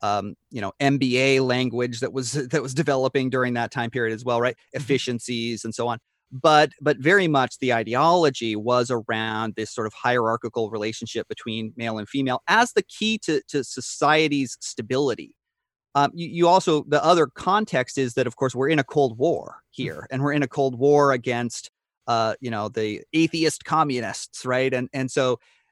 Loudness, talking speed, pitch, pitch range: -23 LUFS, 185 wpm, 130 Hz, 115-145 Hz